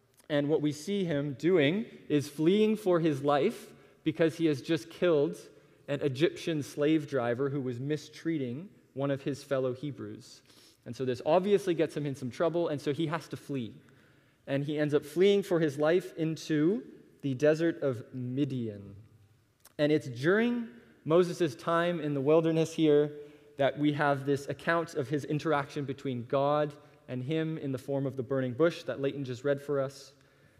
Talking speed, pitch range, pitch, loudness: 175 wpm, 135-160 Hz, 145 Hz, -30 LUFS